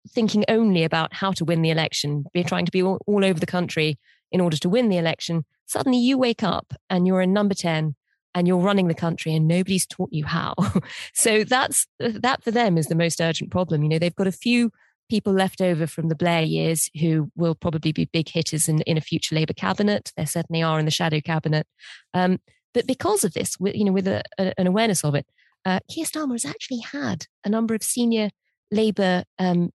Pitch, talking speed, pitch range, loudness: 180 Hz, 220 wpm, 160-205 Hz, -23 LUFS